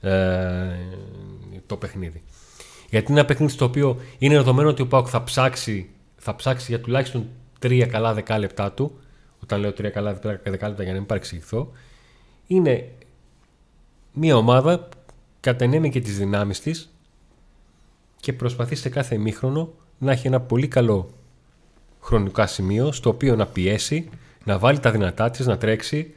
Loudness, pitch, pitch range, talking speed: -22 LUFS, 120 Hz, 100-135 Hz, 145 wpm